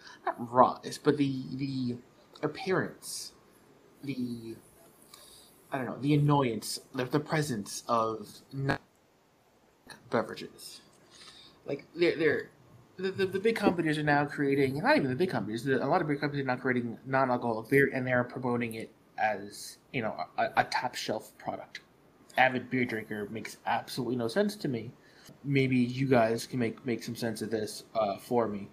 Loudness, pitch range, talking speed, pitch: -31 LUFS, 120-145 Hz, 160 wpm, 130 Hz